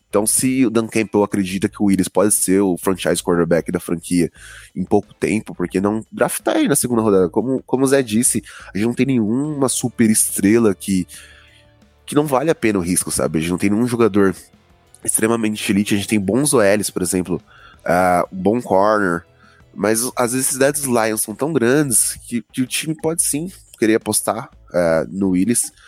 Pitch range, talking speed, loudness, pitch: 90-120 Hz, 195 wpm, -18 LUFS, 105 Hz